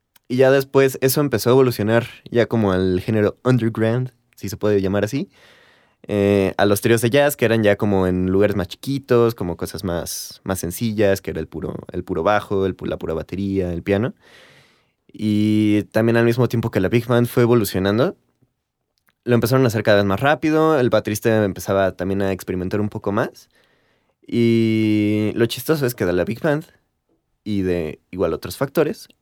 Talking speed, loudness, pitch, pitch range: 190 wpm, -19 LUFS, 105 Hz, 95-120 Hz